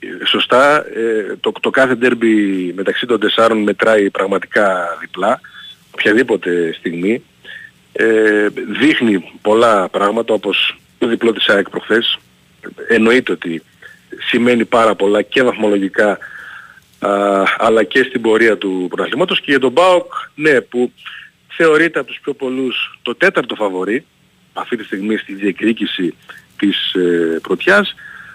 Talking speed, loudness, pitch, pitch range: 125 wpm, -14 LUFS, 115 Hz, 100-130 Hz